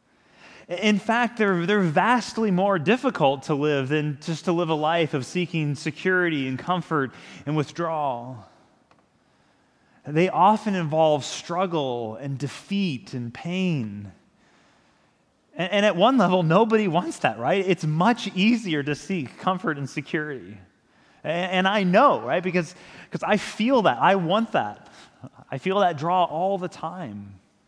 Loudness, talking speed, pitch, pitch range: -23 LUFS, 145 wpm, 170 Hz, 145-195 Hz